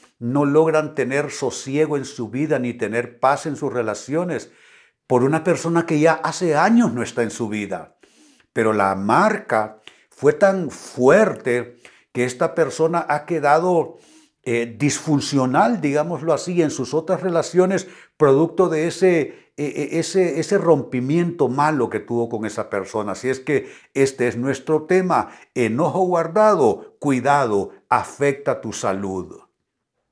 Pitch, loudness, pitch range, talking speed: 145 Hz, -20 LUFS, 125-165 Hz, 140 wpm